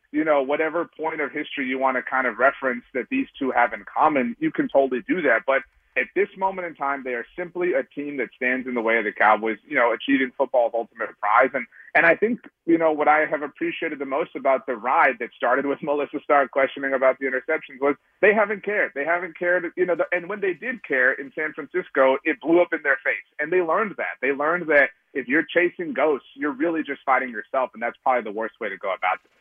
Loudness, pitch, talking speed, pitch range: -23 LUFS, 150 Hz, 250 wpm, 135-180 Hz